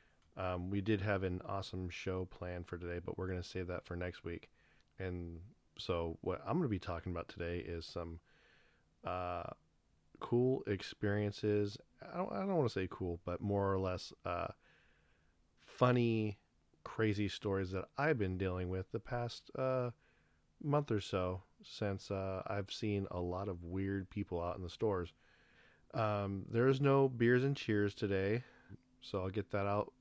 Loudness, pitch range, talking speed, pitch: -39 LUFS, 90-110 Hz, 170 wpm, 95 Hz